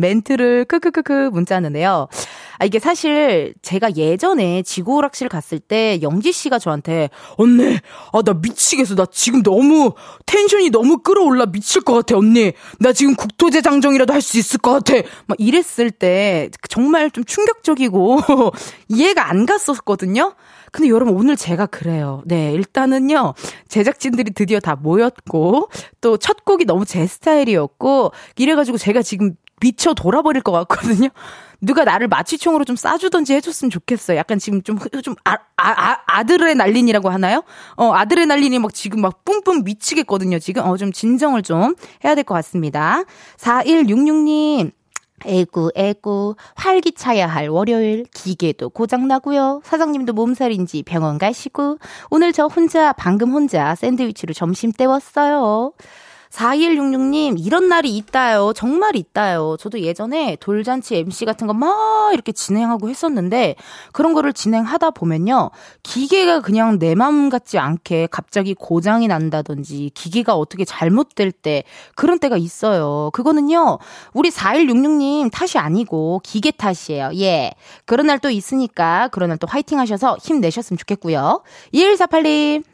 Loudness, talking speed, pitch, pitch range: -16 LUFS, 315 characters per minute, 240 Hz, 190-290 Hz